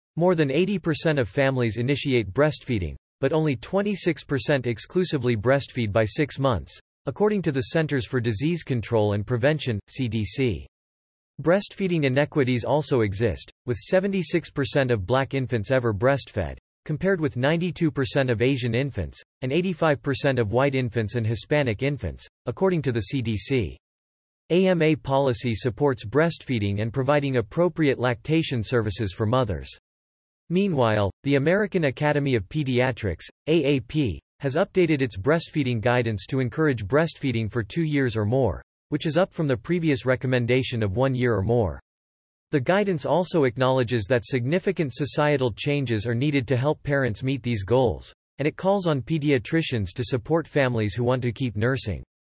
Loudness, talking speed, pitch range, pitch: -24 LUFS, 145 wpm, 115-150 Hz, 130 Hz